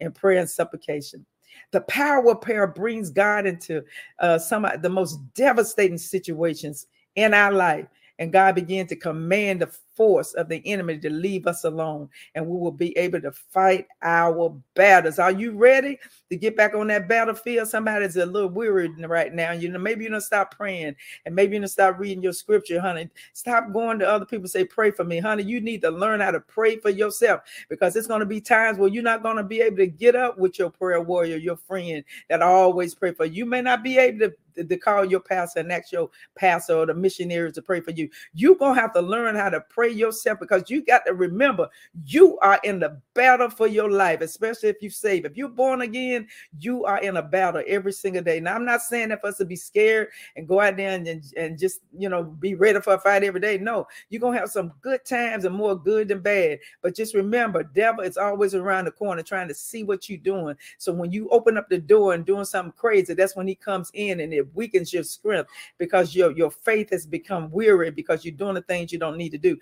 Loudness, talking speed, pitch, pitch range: -22 LUFS, 235 wpm, 195 Hz, 175-220 Hz